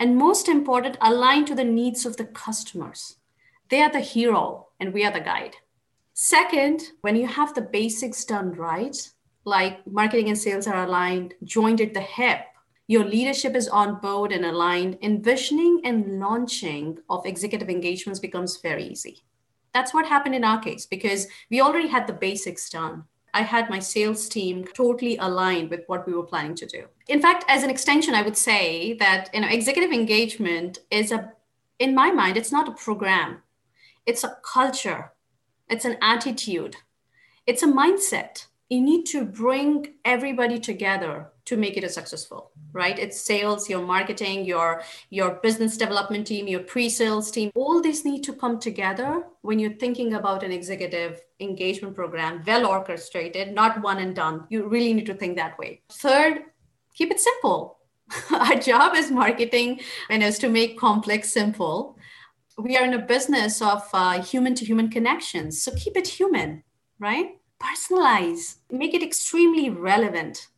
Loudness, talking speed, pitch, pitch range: -23 LUFS, 165 wpm, 220 Hz, 190-260 Hz